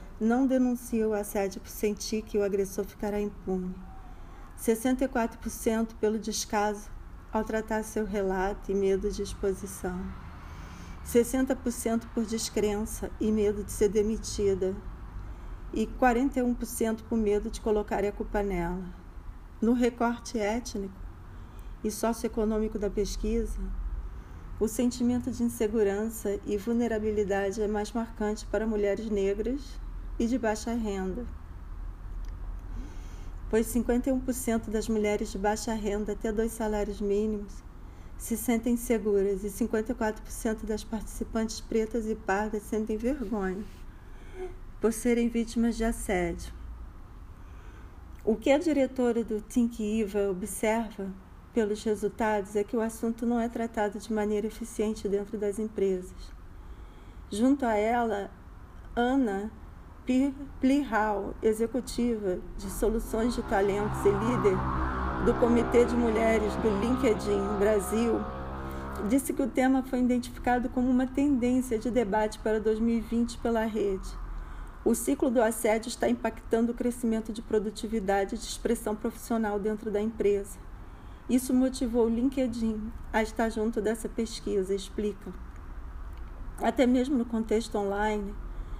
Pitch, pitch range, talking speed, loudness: 215 Hz, 200-230 Hz, 120 wpm, -29 LUFS